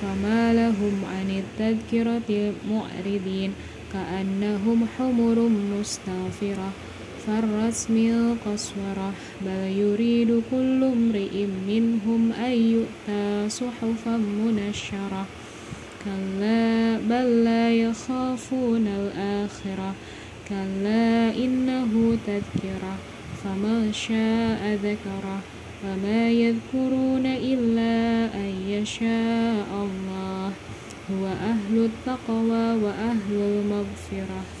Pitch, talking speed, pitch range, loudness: 215 Hz, 70 wpm, 195-230 Hz, -25 LUFS